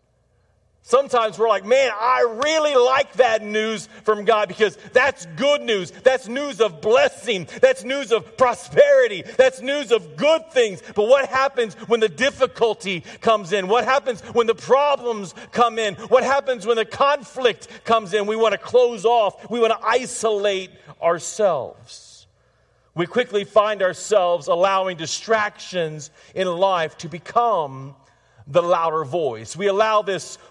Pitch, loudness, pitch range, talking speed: 220 Hz, -20 LUFS, 185-250 Hz, 150 wpm